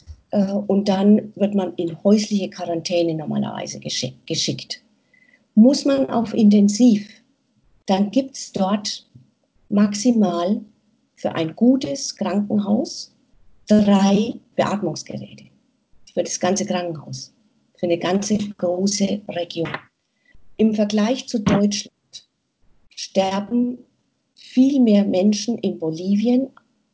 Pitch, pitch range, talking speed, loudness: 205 Hz, 180-235 Hz, 95 wpm, -20 LUFS